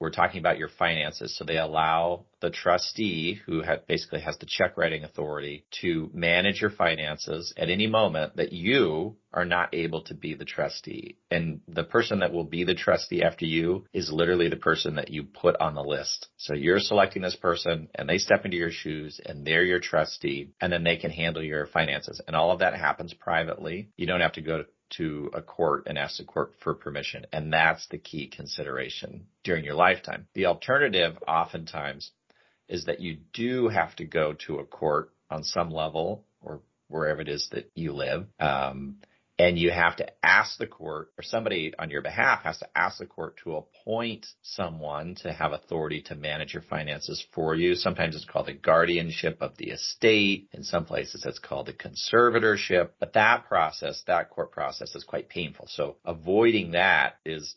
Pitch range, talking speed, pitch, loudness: 80-90 Hz, 195 wpm, 85 Hz, -27 LUFS